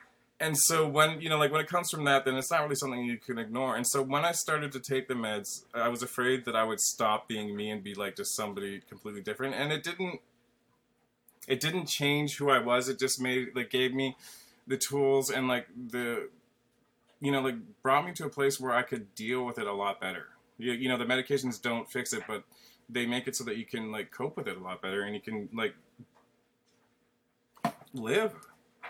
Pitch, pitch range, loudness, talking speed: 130 Hz, 120-145 Hz, -31 LUFS, 225 wpm